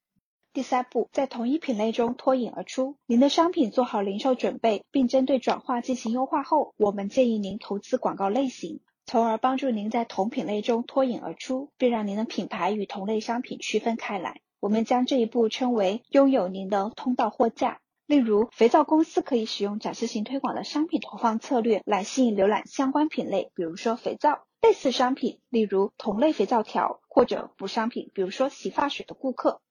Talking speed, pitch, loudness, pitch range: 305 characters per minute, 240 Hz, -26 LUFS, 215-265 Hz